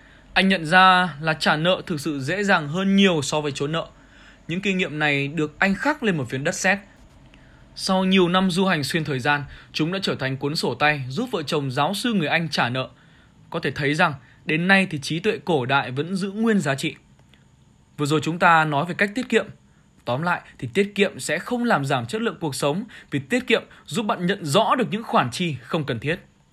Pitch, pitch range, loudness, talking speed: 170 Hz, 150-195 Hz, -22 LUFS, 235 wpm